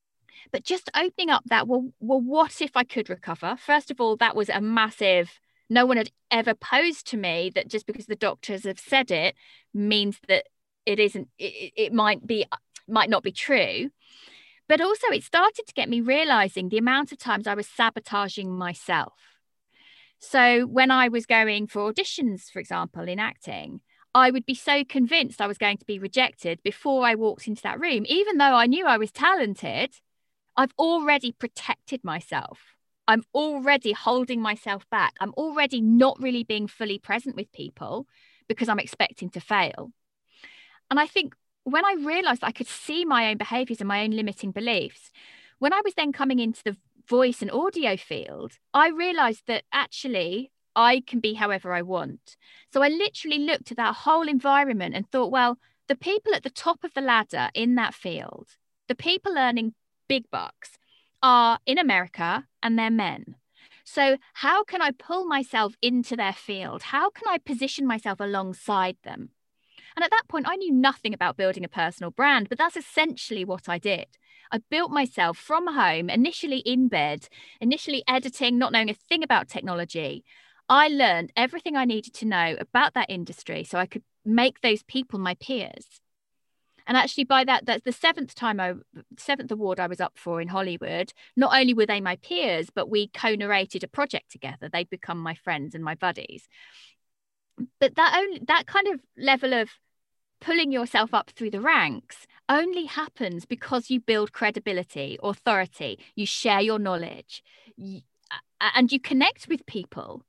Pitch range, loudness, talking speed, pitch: 205-280 Hz, -24 LUFS, 175 wpm, 240 Hz